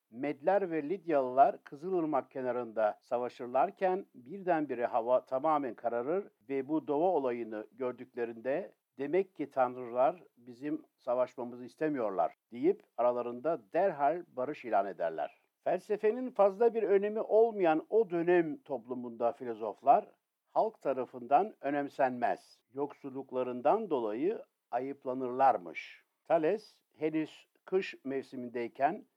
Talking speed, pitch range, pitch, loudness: 95 wpm, 125-180 Hz, 140 Hz, -33 LUFS